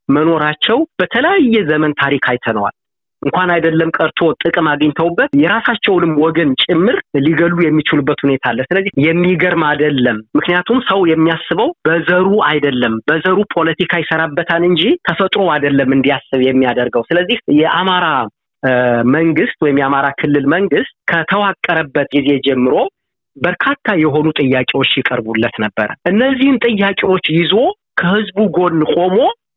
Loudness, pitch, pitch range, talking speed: -13 LUFS, 160 Hz, 140-185 Hz, 110 wpm